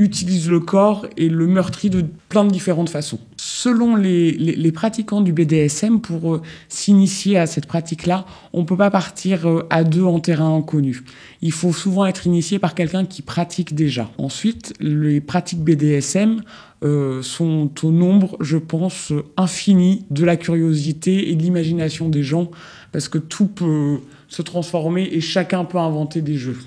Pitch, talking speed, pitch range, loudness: 170 Hz, 175 wpm, 155-185 Hz, -18 LUFS